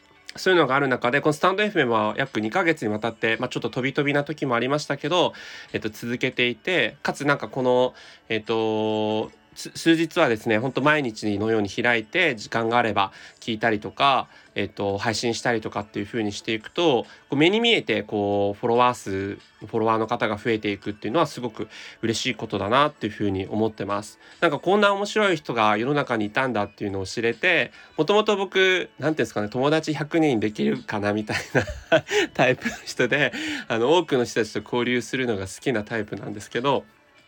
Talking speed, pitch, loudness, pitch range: 420 characters per minute, 115 Hz, -23 LUFS, 110-145 Hz